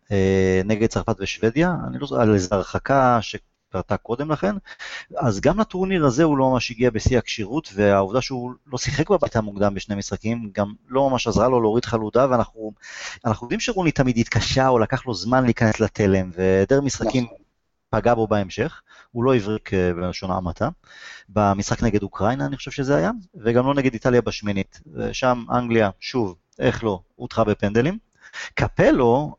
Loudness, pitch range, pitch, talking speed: -21 LUFS, 105-130 Hz, 115 Hz, 155 wpm